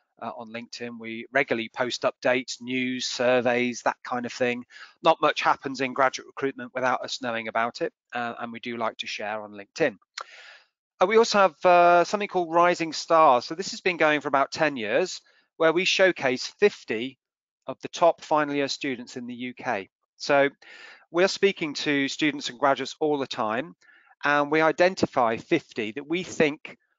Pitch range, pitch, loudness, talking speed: 125-165 Hz, 140 Hz, -25 LUFS, 180 wpm